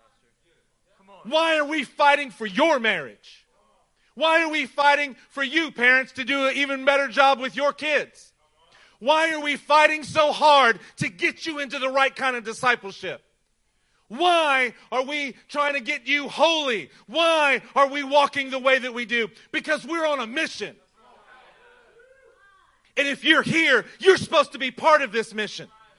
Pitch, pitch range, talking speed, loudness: 280 Hz, 255-310 Hz, 165 wpm, -21 LUFS